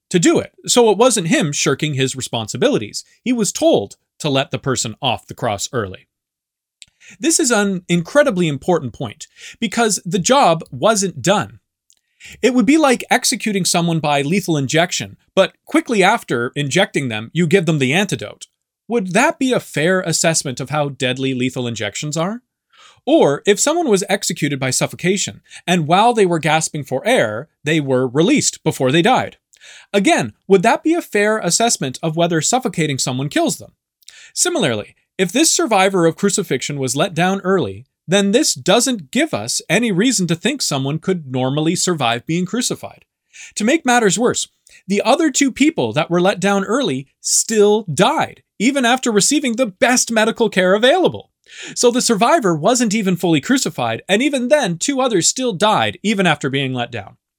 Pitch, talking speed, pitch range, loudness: 190 Hz, 170 wpm, 150-230 Hz, -16 LUFS